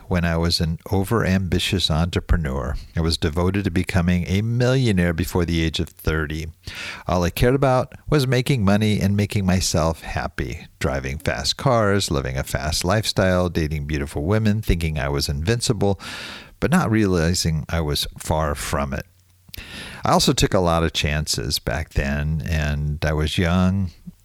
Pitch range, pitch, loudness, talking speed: 80-100 Hz, 90 Hz, -21 LUFS, 160 wpm